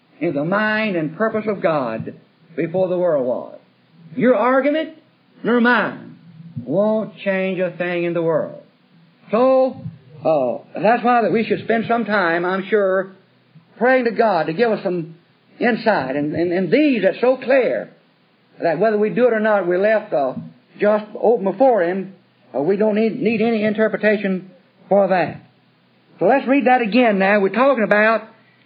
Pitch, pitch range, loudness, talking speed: 210 Hz, 185-230 Hz, -18 LUFS, 170 wpm